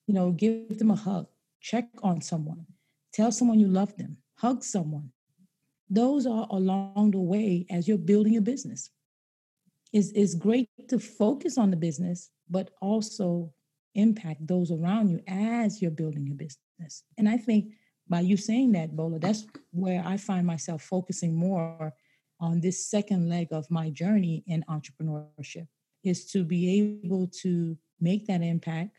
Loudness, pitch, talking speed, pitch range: -28 LUFS, 185 Hz, 165 wpm, 165-210 Hz